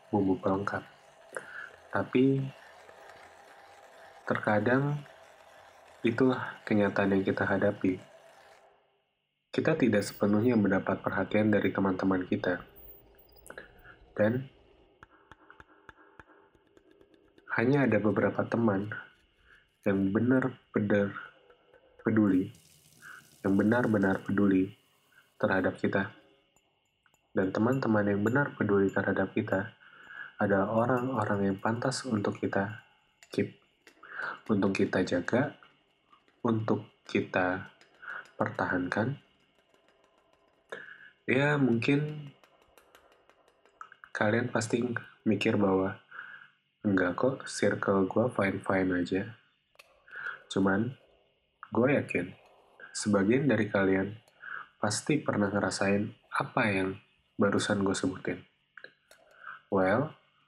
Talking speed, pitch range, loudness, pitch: 75 wpm, 100-120 Hz, -30 LUFS, 105 Hz